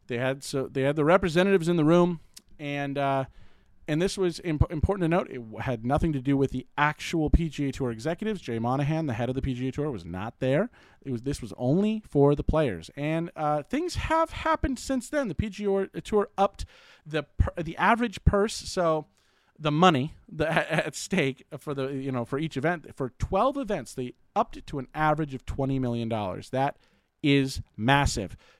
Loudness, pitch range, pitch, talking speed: -27 LUFS, 130-175 Hz, 145 Hz, 195 wpm